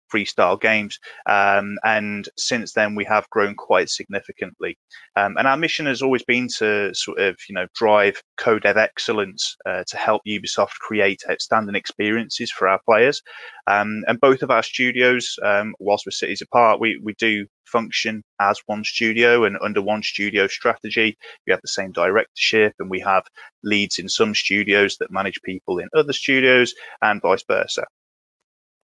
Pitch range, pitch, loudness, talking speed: 100-120 Hz, 105 Hz, -20 LUFS, 170 wpm